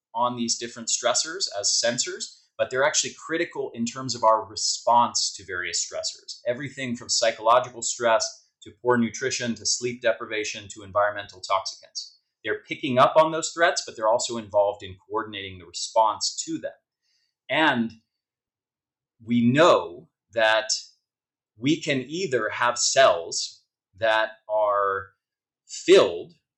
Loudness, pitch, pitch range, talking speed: -24 LUFS, 115 Hz, 105-130 Hz, 135 wpm